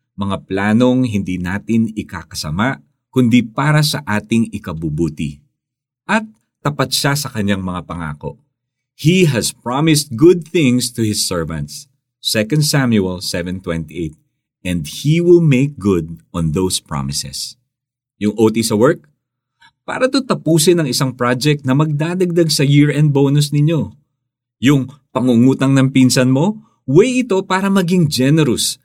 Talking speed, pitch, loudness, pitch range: 130 wpm, 130 Hz, -15 LUFS, 100-150 Hz